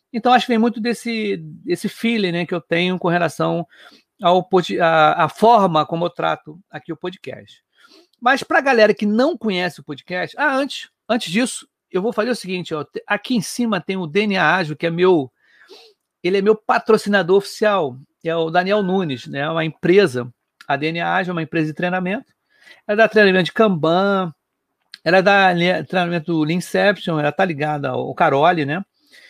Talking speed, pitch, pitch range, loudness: 185 wpm, 185 Hz, 170-215 Hz, -18 LUFS